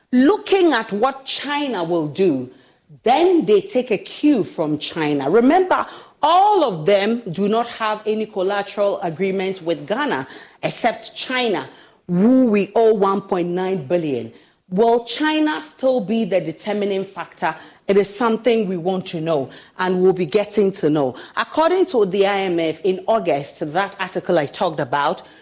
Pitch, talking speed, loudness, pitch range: 200 Hz, 150 wpm, -19 LUFS, 175-235 Hz